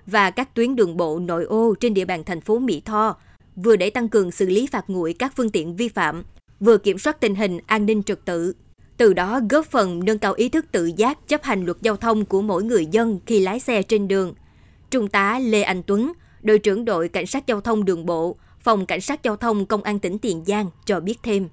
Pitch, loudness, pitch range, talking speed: 210 Hz, -21 LUFS, 190-230 Hz, 245 wpm